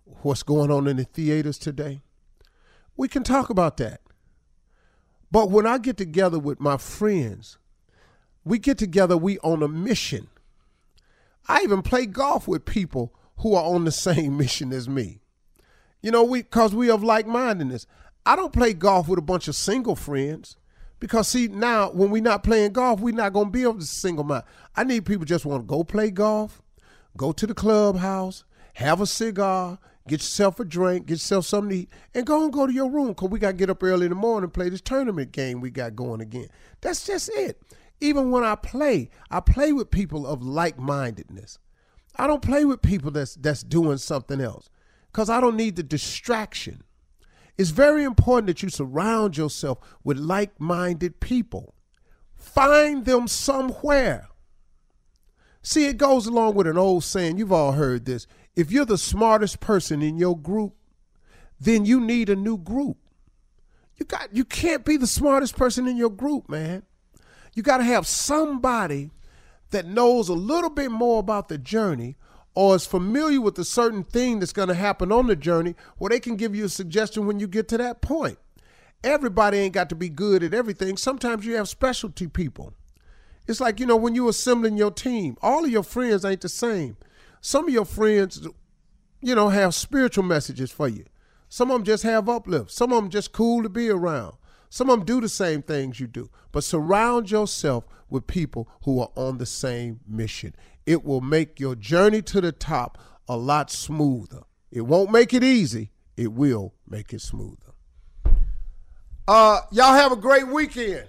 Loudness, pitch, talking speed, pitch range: -23 LUFS, 195 Hz, 190 wpm, 150-235 Hz